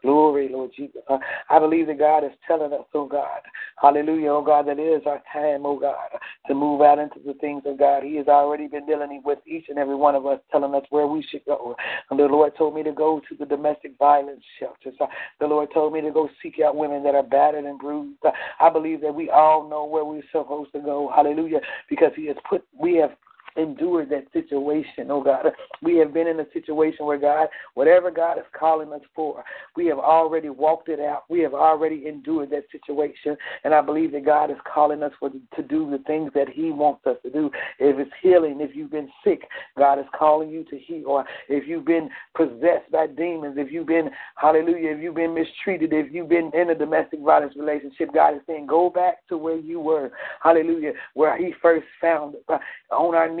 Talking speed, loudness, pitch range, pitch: 225 wpm, -22 LUFS, 145-160 Hz, 150 Hz